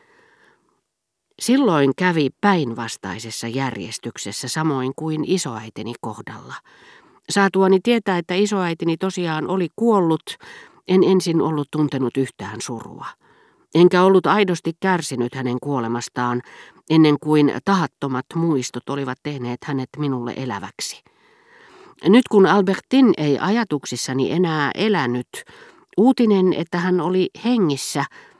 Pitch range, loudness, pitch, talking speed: 130-190 Hz, -20 LUFS, 160 Hz, 100 wpm